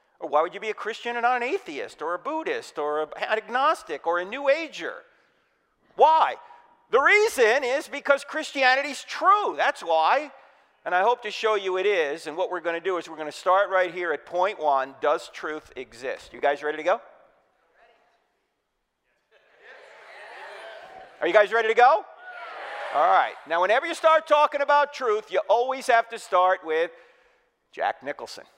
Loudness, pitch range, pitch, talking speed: -24 LUFS, 180-295 Hz, 235 Hz, 180 wpm